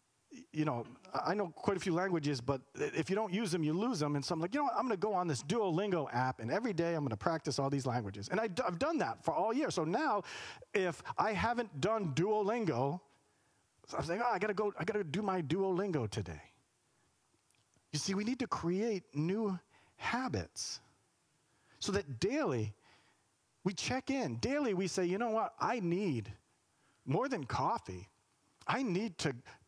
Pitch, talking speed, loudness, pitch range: 175 Hz, 200 wpm, -36 LUFS, 135-210 Hz